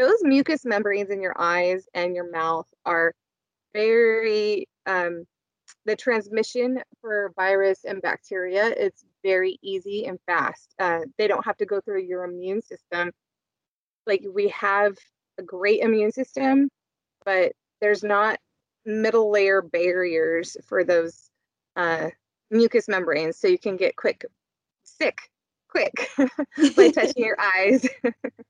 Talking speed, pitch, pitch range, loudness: 135 wpm, 205 Hz, 185-260 Hz, -23 LUFS